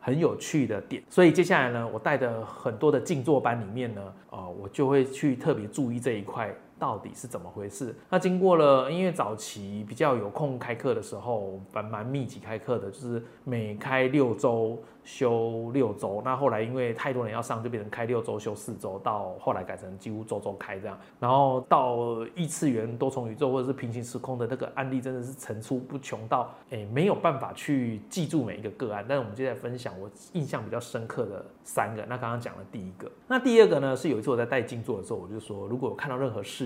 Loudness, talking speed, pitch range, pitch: -28 LUFS, 335 characters per minute, 110-135 Hz, 120 Hz